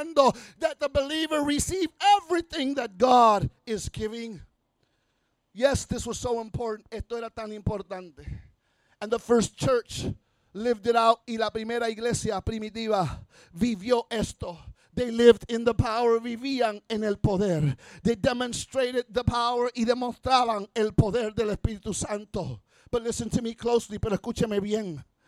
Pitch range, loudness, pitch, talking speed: 210-245 Hz, -26 LUFS, 230 Hz, 140 wpm